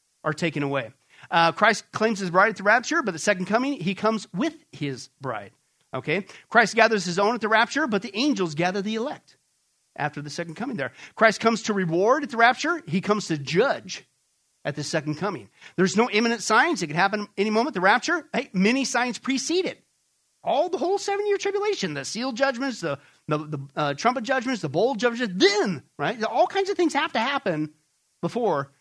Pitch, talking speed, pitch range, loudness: 220 Hz, 205 wpm, 170-265 Hz, -24 LUFS